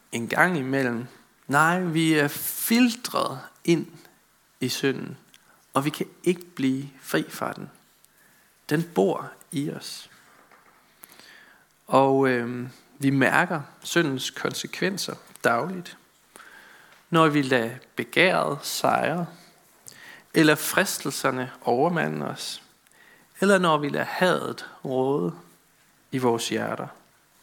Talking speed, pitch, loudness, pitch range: 105 wpm, 145 Hz, -25 LUFS, 130-170 Hz